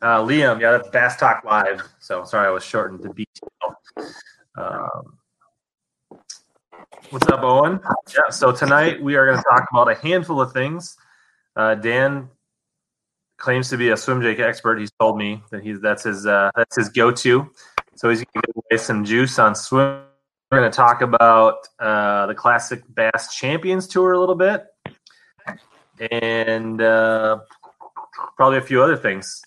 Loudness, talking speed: -18 LUFS, 165 wpm